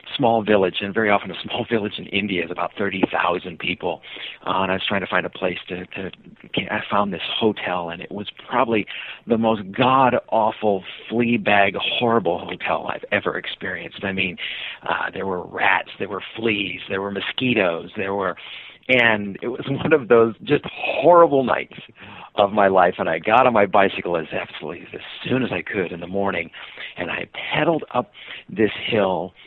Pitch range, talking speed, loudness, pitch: 95-115 Hz, 190 wpm, -21 LUFS, 100 Hz